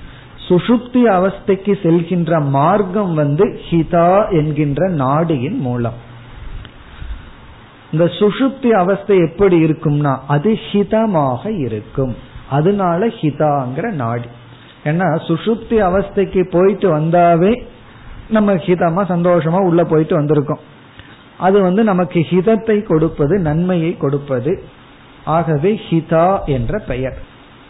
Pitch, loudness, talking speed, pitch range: 170 Hz, -15 LUFS, 80 wpm, 140-195 Hz